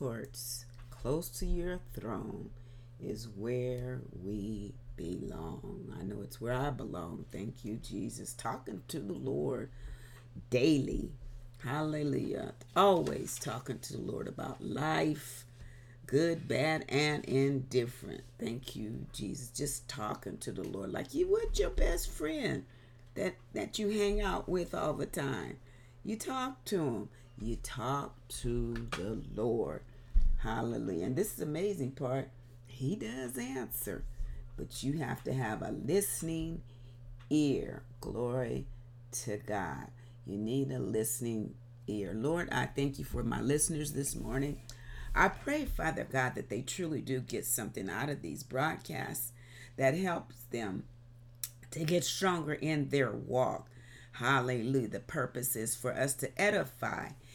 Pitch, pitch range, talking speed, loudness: 125 Hz, 120-145 Hz, 140 wpm, -36 LUFS